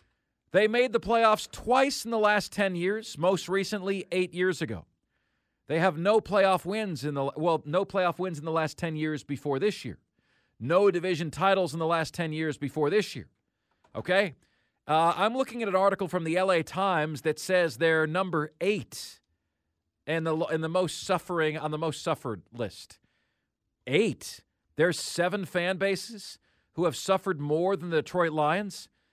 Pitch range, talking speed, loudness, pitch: 155-195 Hz, 175 wpm, -28 LUFS, 175 Hz